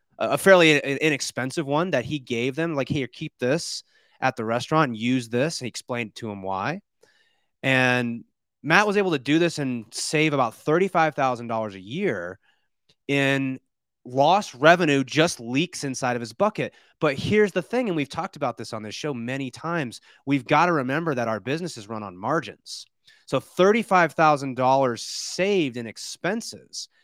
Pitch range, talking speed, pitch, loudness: 125-165 Hz, 175 wpm, 140 Hz, -23 LUFS